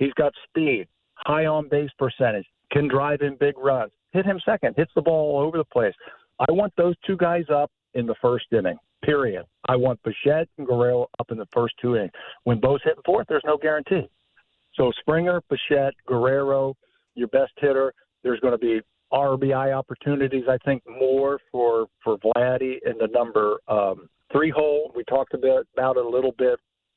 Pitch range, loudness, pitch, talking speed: 125-150 Hz, -23 LUFS, 135 Hz, 190 wpm